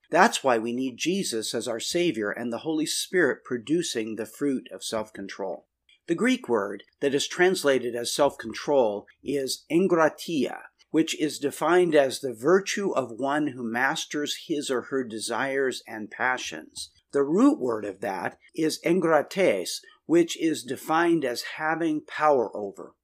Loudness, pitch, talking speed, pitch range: -26 LUFS, 145 Hz, 155 wpm, 120-165 Hz